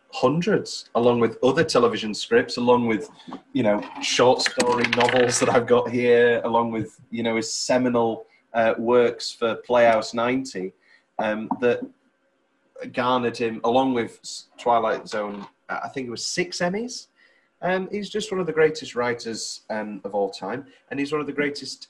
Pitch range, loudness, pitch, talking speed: 115-140 Hz, -23 LUFS, 120 Hz, 165 wpm